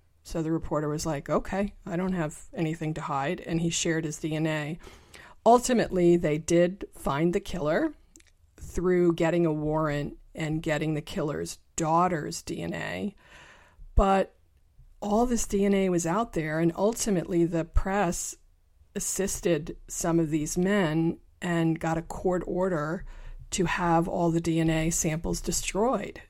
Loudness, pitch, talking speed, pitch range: -28 LUFS, 165 Hz, 140 wpm, 155-185 Hz